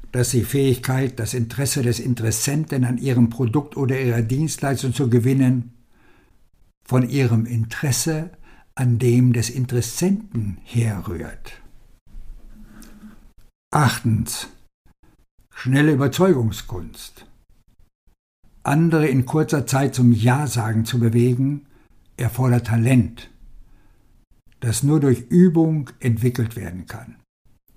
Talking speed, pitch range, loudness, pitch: 95 wpm, 115-135 Hz, -20 LUFS, 125 Hz